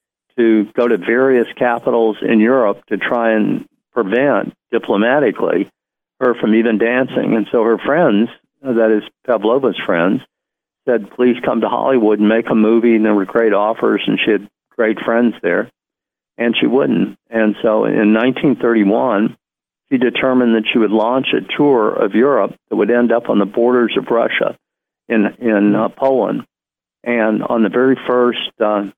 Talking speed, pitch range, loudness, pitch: 165 wpm, 110-120 Hz, -15 LUFS, 115 Hz